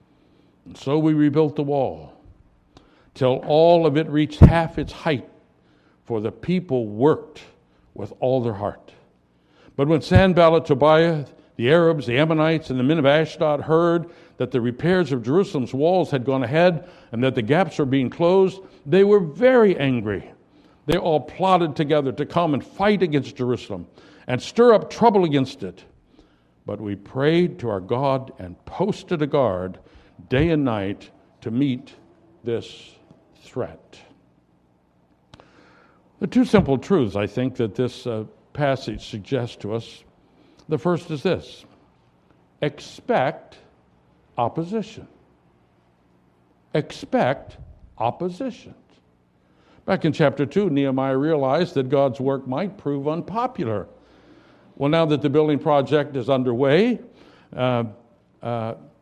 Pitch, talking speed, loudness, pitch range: 140 Hz, 135 wpm, -21 LUFS, 115-165 Hz